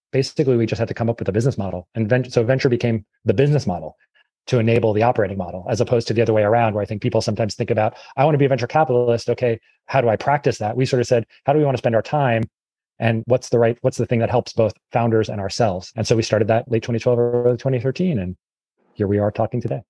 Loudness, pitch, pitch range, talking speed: -20 LUFS, 115 Hz, 110-125 Hz, 275 wpm